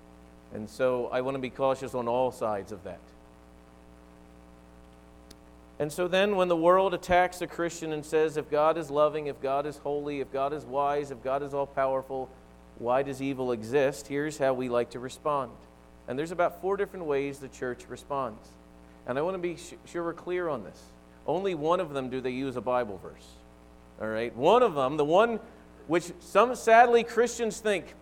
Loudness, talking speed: -28 LUFS, 195 wpm